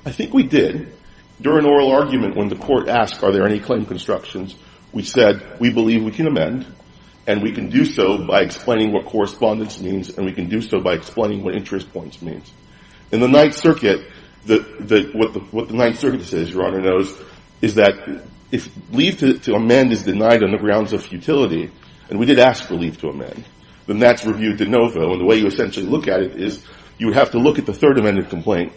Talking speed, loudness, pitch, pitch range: 220 wpm, -17 LUFS, 110 Hz, 95-120 Hz